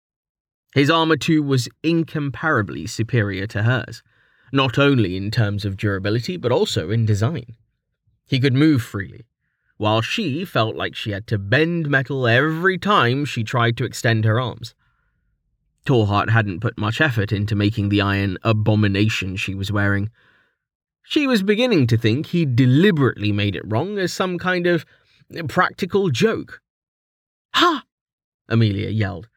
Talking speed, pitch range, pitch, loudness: 145 wpm, 105-150 Hz, 115 Hz, -20 LUFS